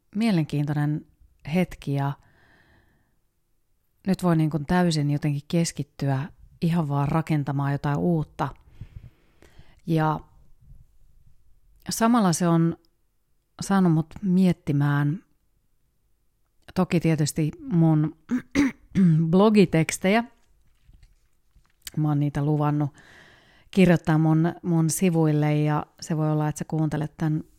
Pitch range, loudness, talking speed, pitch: 145-175 Hz, -24 LUFS, 90 wpm, 160 Hz